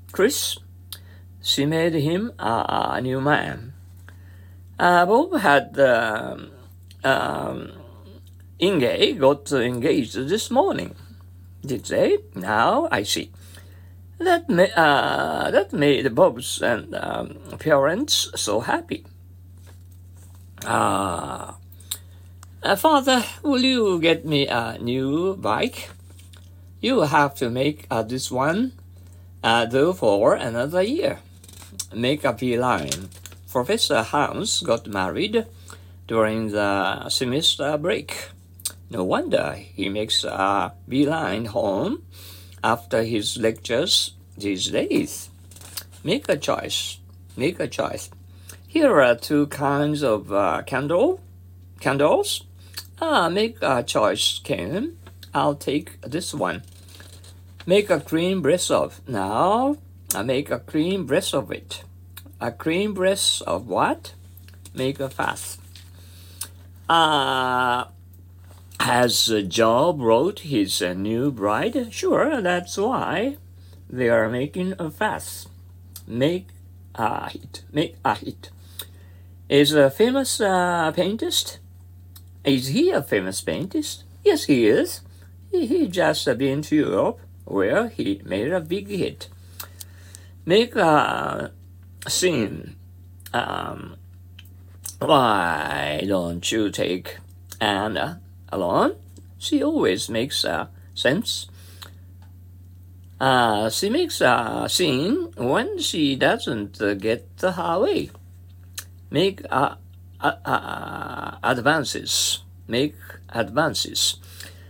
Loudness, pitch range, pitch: -22 LUFS, 90-130 Hz, 90 Hz